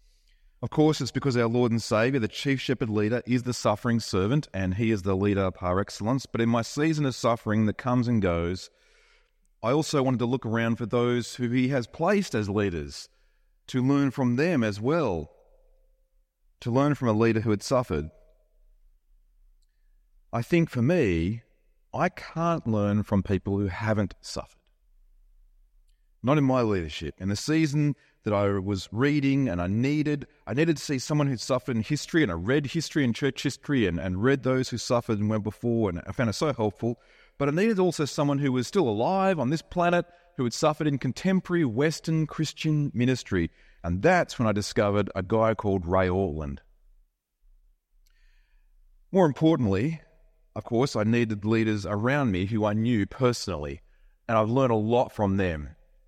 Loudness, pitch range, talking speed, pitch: -26 LUFS, 100-145 Hz, 180 wpm, 120 Hz